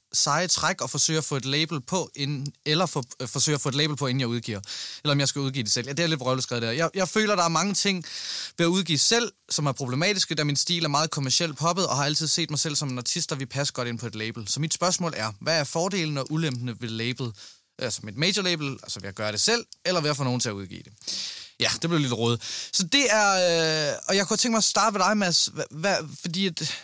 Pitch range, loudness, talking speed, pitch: 130-175 Hz, -24 LUFS, 285 wpm, 150 Hz